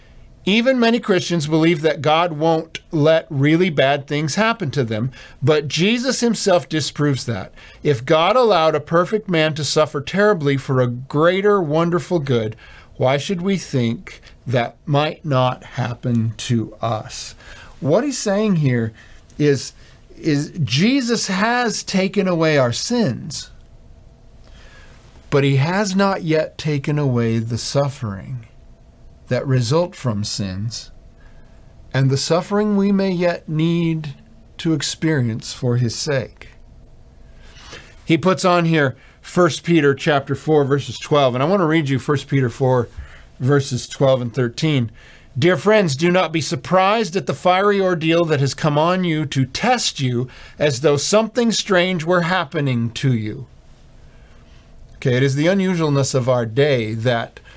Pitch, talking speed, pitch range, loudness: 150 Hz, 145 wpm, 130-180 Hz, -18 LUFS